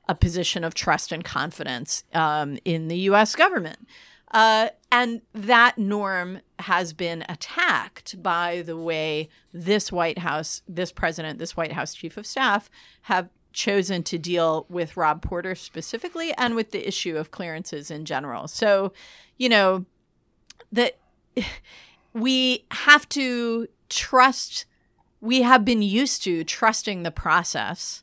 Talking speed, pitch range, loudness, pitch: 135 wpm, 165-225 Hz, -23 LUFS, 185 Hz